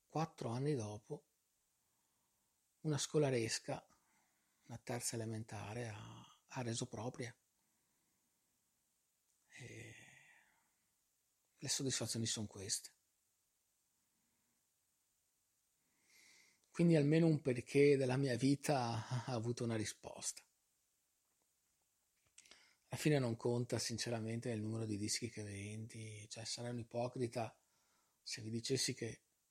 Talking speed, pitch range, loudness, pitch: 95 wpm, 115-130 Hz, -40 LUFS, 120 Hz